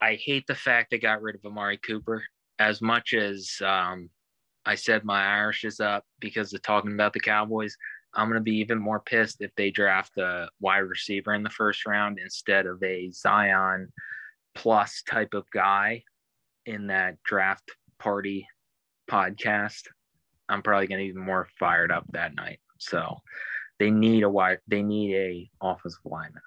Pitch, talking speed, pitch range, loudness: 105 Hz, 170 wpm, 95-110 Hz, -26 LUFS